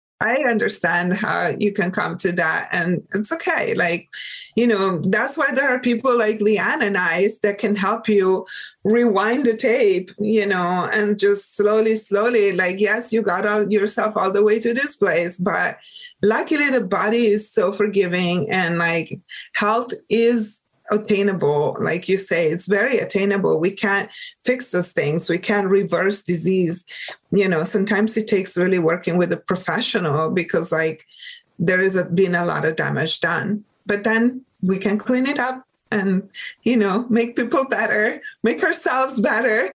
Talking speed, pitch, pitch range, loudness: 170 wpm, 205 Hz, 185-230 Hz, -19 LUFS